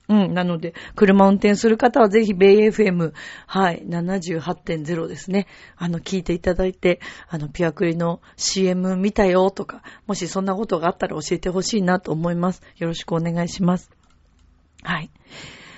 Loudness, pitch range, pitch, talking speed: -20 LUFS, 170-195 Hz, 180 Hz, 270 characters per minute